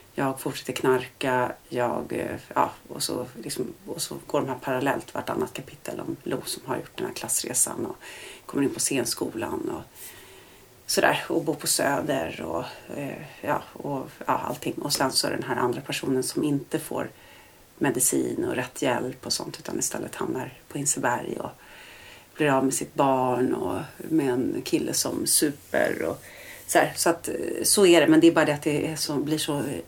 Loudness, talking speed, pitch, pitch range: -26 LUFS, 185 wpm, 150 Hz, 130-160 Hz